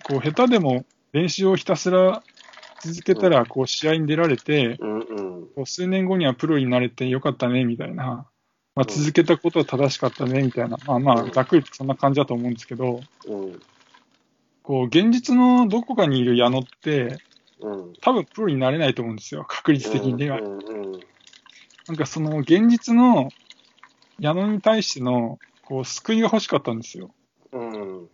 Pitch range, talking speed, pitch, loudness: 125-170 Hz, 330 characters per minute, 140 Hz, -21 LUFS